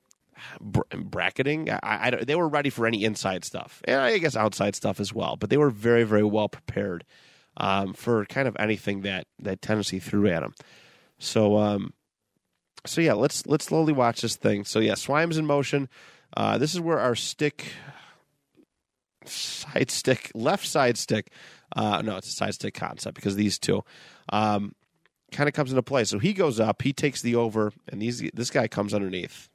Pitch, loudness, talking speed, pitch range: 115 Hz, -26 LUFS, 185 wpm, 105-140 Hz